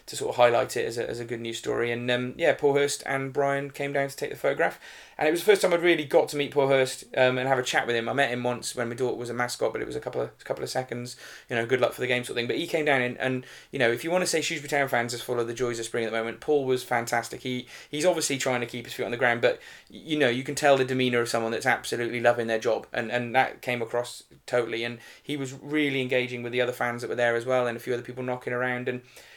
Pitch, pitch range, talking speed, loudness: 125 Hz, 120-140 Hz, 325 wpm, -27 LUFS